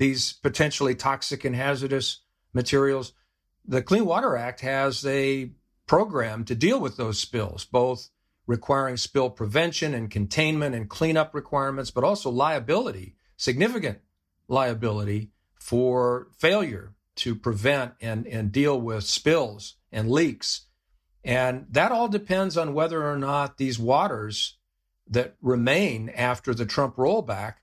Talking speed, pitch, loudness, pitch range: 130 wpm, 125 Hz, -25 LUFS, 110-140 Hz